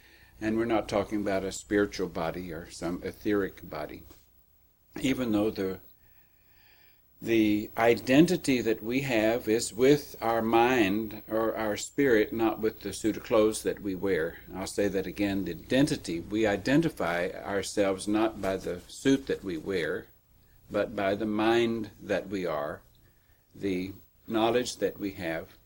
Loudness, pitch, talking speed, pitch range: -29 LUFS, 105 Hz, 150 wpm, 100-115 Hz